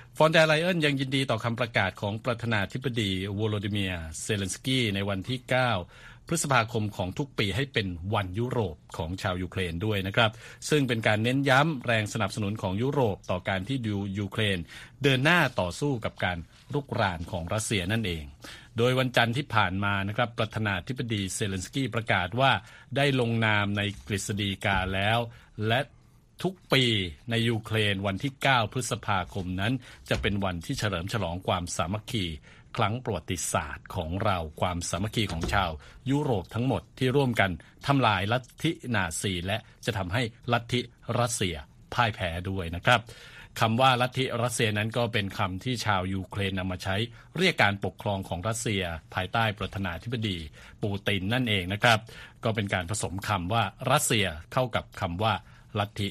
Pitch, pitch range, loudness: 110 Hz, 95-125 Hz, -28 LUFS